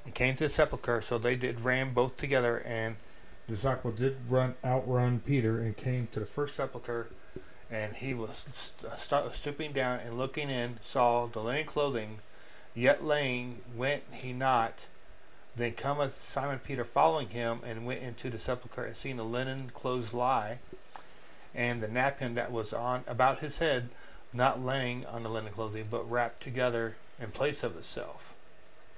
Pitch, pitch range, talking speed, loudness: 125 Hz, 115-130 Hz, 170 wpm, -32 LUFS